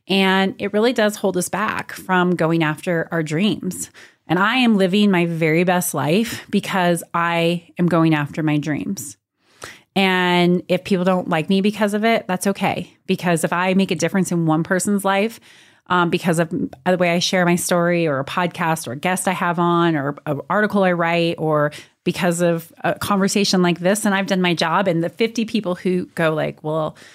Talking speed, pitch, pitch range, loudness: 200 wpm, 180 Hz, 165-195 Hz, -19 LUFS